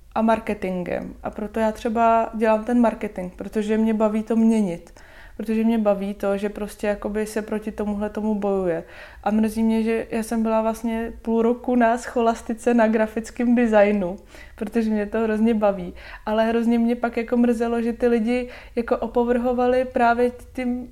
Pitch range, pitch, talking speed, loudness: 215-235 Hz, 225 Hz, 170 wpm, -22 LUFS